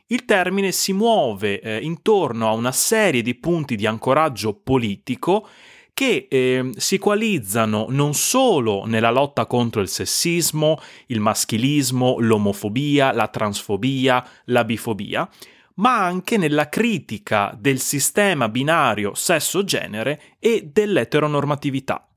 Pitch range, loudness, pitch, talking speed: 110-170 Hz, -20 LUFS, 130 Hz, 115 wpm